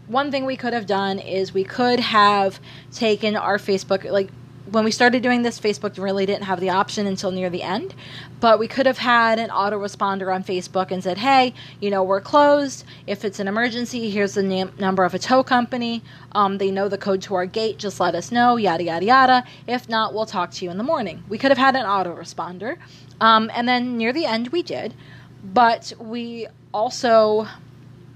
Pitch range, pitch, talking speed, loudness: 190-240 Hz, 210 Hz, 210 wpm, -20 LUFS